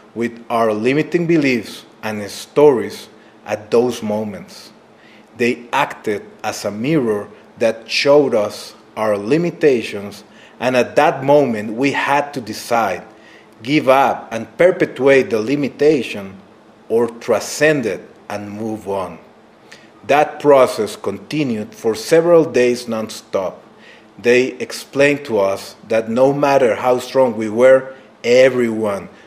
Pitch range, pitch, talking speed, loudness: 110-140 Hz, 120 Hz, 120 wpm, -16 LUFS